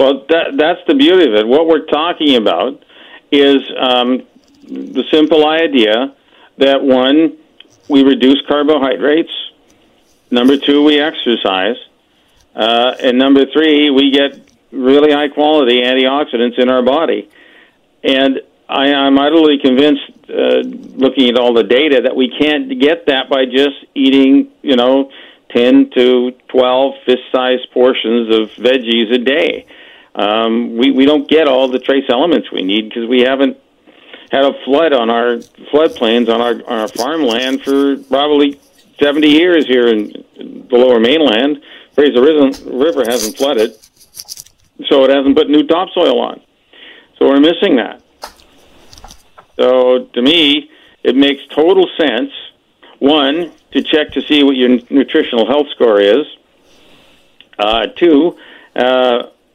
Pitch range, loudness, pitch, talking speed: 125-150 Hz, -11 LUFS, 135 Hz, 140 wpm